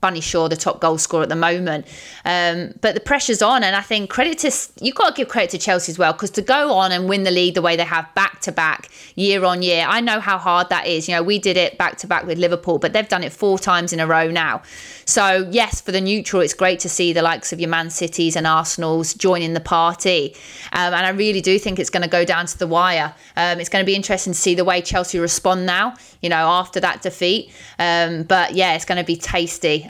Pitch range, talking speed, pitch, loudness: 170-195 Hz, 265 wpm, 180 Hz, -18 LUFS